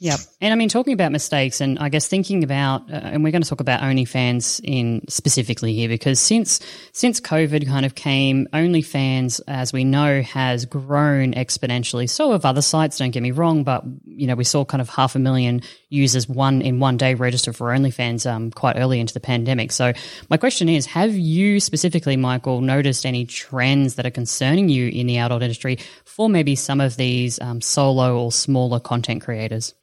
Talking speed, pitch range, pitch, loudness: 200 wpm, 125-145 Hz, 130 Hz, -19 LUFS